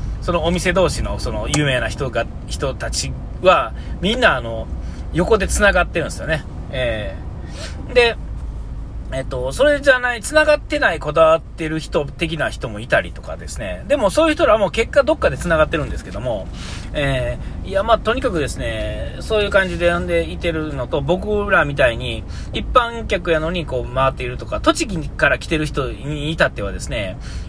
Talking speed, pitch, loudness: 360 characters per minute, 165 Hz, -19 LUFS